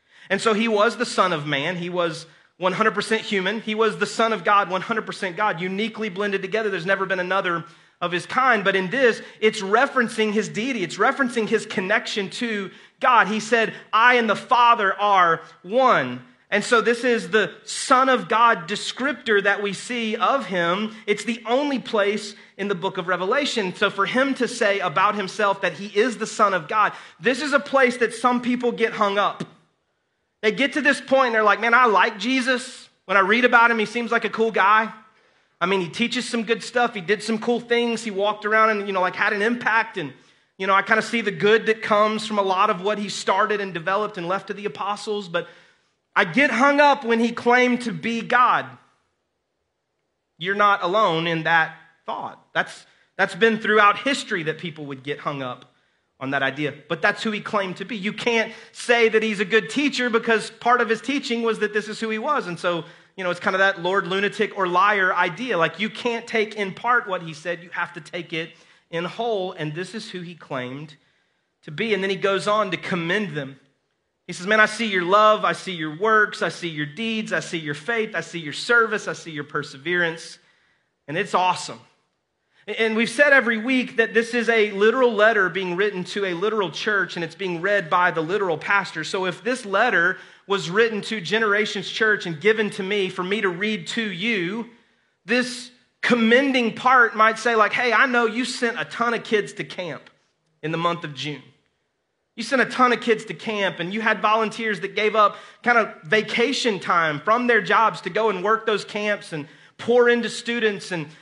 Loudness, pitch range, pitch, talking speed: -21 LUFS, 185-230 Hz, 210 Hz, 215 wpm